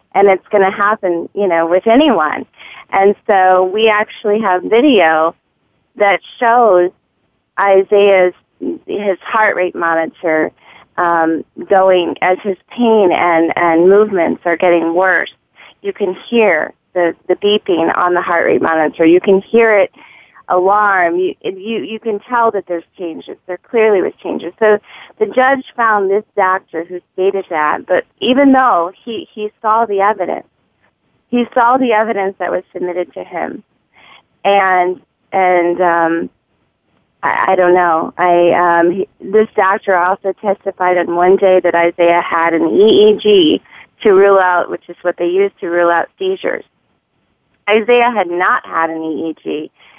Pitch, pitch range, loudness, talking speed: 190 Hz, 175-215 Hz, -13 LUFS, 150 wpm